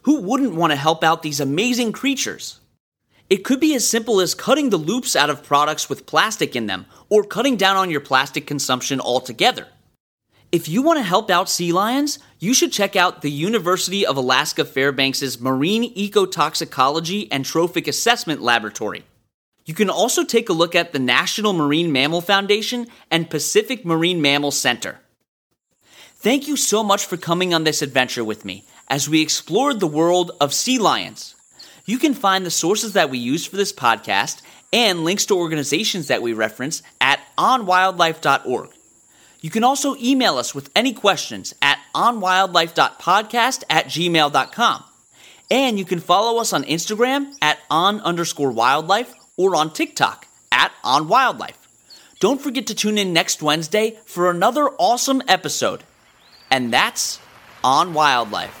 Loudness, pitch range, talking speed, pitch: -18 LUFS, 150-225 Hz, 155 wpm, 175 Hz